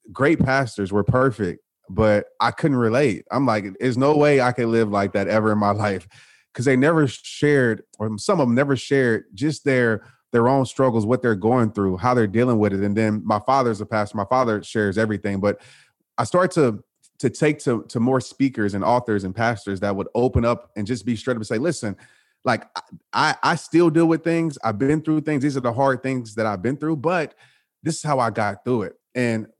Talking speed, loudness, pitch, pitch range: 225 wpm, -21 LUFS, 120 Hz, 105-135 Hz